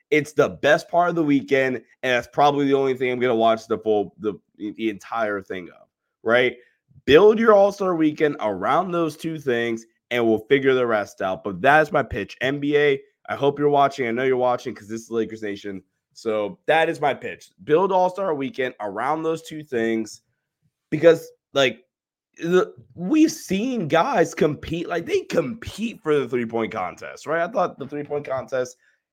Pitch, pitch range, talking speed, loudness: 135 Hz, 115-160 Hz, 180 wpm, -22 LUFS